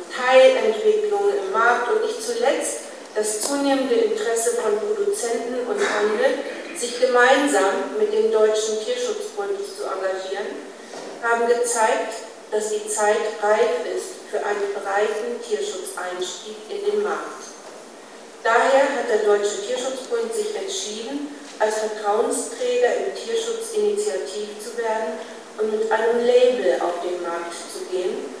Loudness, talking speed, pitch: -22 LUFS, 120 wpm, 255 Hz